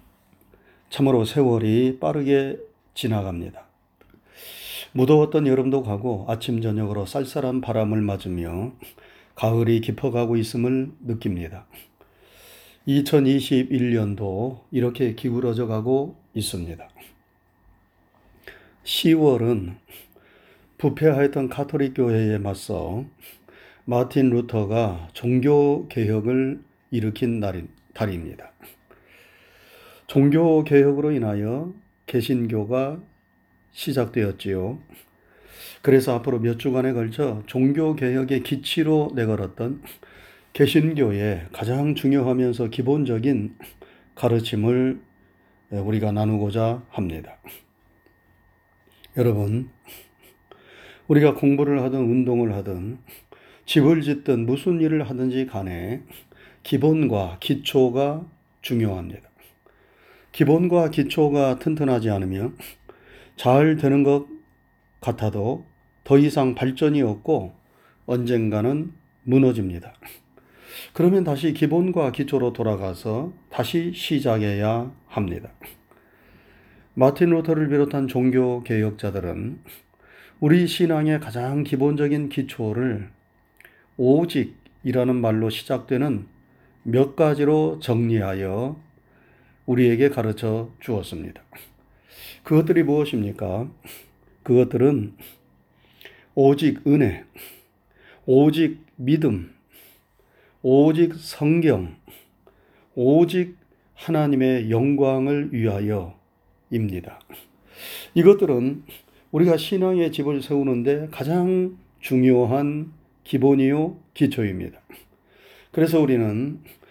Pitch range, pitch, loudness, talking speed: 110-145 Hz, 130 Hz, -22 LUFS, 210 characters per minute